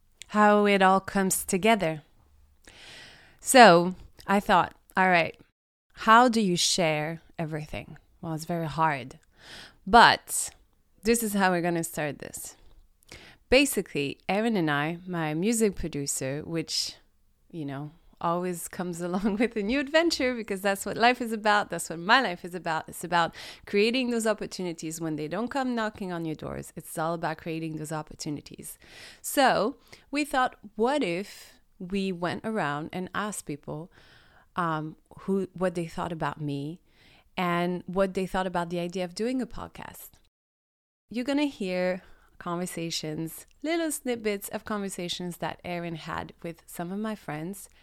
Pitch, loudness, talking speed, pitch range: 180 Hz, -27 LUFS, 155 wpm, 160-210 Hz